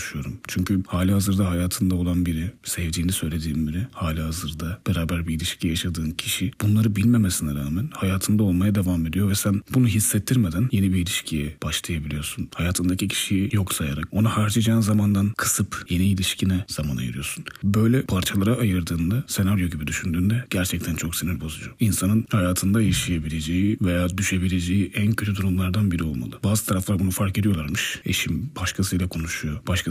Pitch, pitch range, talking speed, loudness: 95 Hz, 85-105 Hz, 145 wpm, -23 LUFS